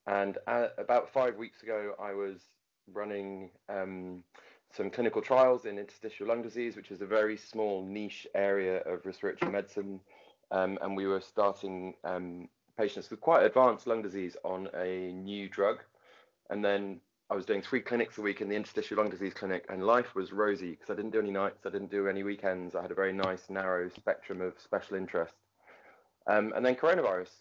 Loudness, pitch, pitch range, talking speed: -33 LUFS, 100 Hz, 95-105 Hz, 190 wpm